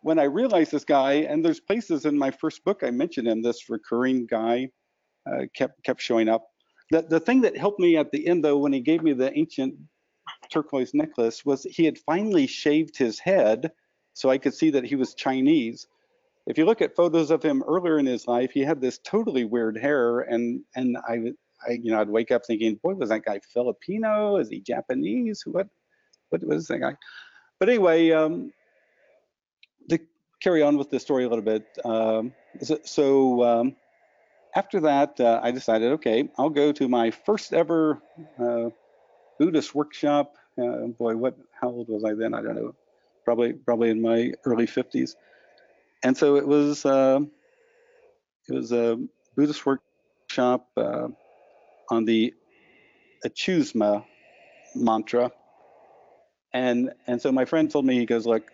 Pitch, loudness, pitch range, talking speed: 140 Hz, -24 LUFS, 120-165 Hz, 170 wpm